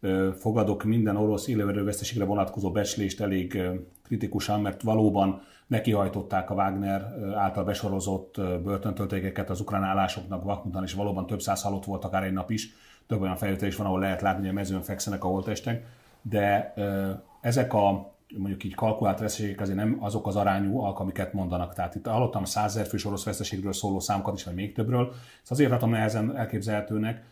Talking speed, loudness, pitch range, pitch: 175 wpm, -28 LUFS, 95-105 Hz, 100 Hz